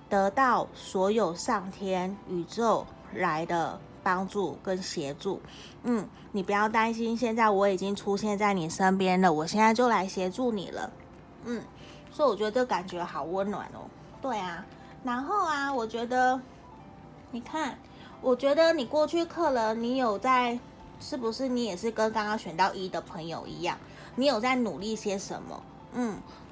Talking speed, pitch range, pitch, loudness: 235 characters per minute, 190-245 Hz, 215 Hz, -29 LUFS